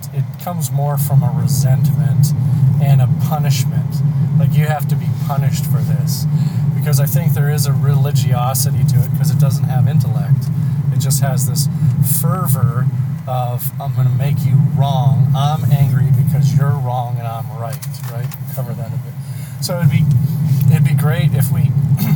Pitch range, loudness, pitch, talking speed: 135-145 Hz, -15 LUFS, 140 Hz, 175 wpm